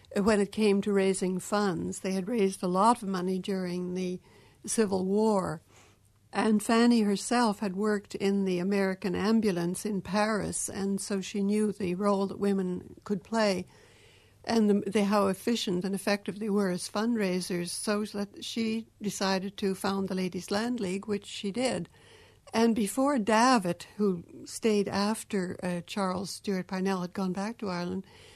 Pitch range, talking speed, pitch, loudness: 190-210 Hz, 160 wpm, 200 Hz, -29 LUFS